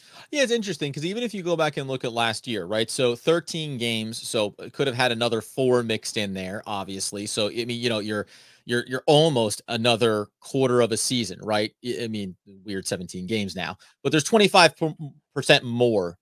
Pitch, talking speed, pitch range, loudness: 120 Hz, 200 wpm, 105-145 Hz, -24 LUFS